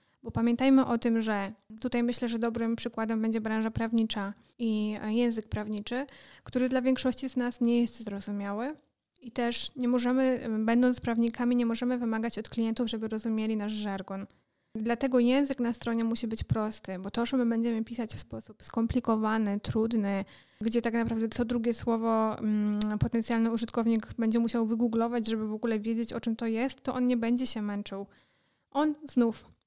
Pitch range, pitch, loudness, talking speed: 220-240 Hz, 230 Hz, -30 LUFS, 170 wpm